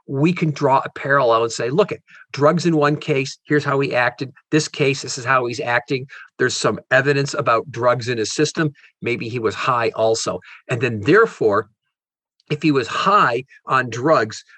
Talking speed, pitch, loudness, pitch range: 190 wpm, 145 Hz, -19 LUFS, 130-150 Hz